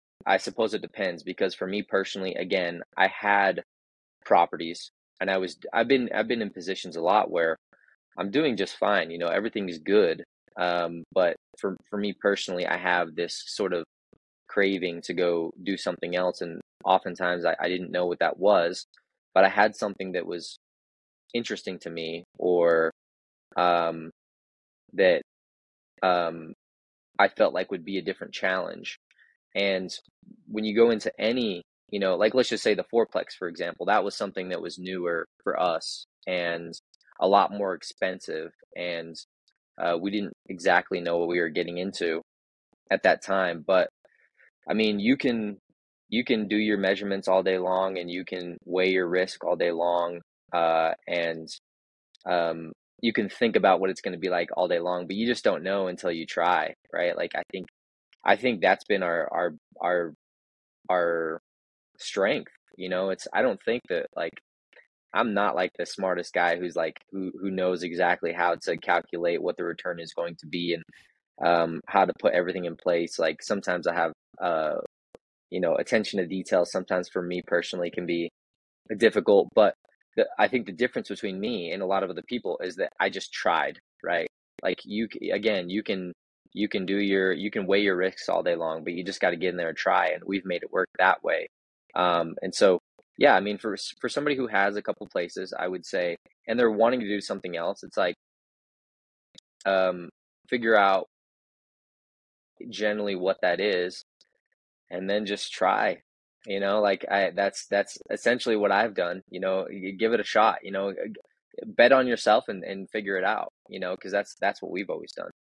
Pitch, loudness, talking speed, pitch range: 90 Hz, -27 LUFS, 190 wpm, 85-100 Hz